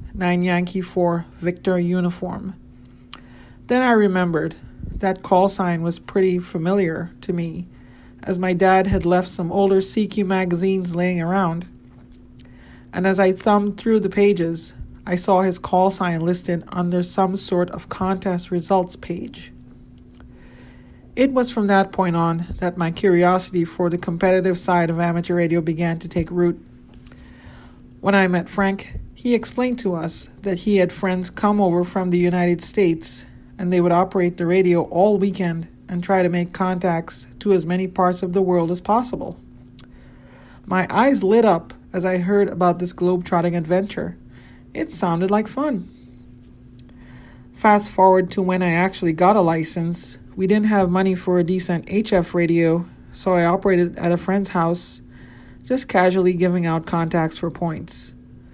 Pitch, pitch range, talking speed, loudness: 180 Hz, 170-190 Hz, 160 wpm, -20 LUFS